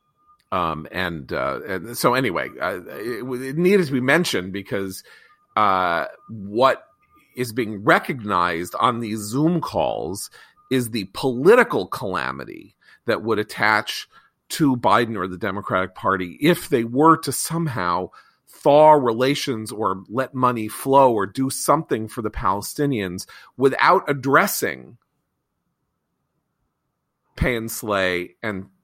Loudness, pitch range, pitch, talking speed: -21 LUFS, 100-150 Hz, 120 Hz, 125 wpm